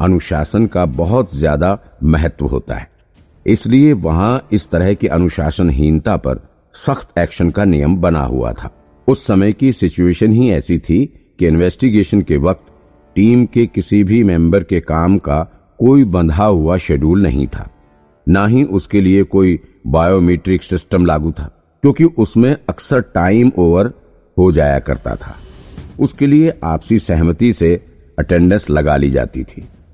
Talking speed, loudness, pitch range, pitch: 150 wpm, -13 LUFS, 80-105 Hz, 90 Hz